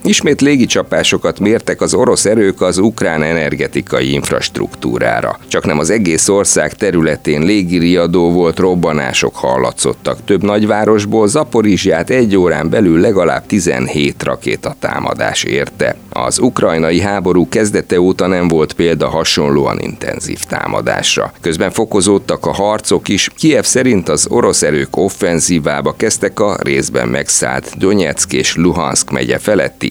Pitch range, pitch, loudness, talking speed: 85-105 Hz, 95 Hz, -12 LUFS, 125 wpm